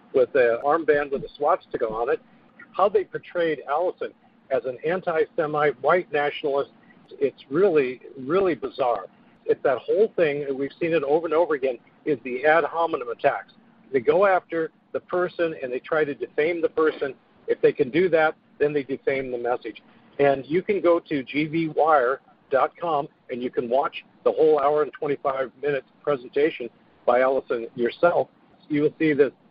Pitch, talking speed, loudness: 170 Hz, 170 wpm, -24 LUFS